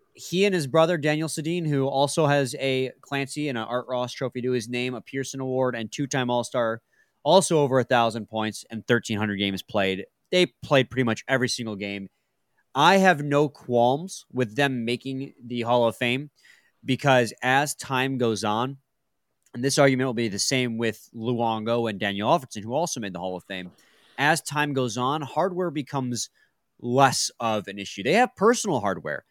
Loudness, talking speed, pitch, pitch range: -24 LUFS, 190 wpm, 130 Hz, 115-145 Hz